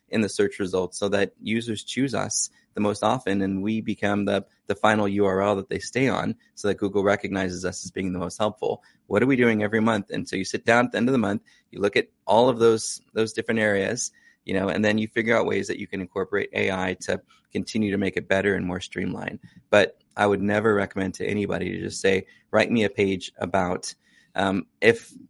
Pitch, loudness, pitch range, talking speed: 100 Hz, -24 LUFS, 95-110 Hz, 230 wpm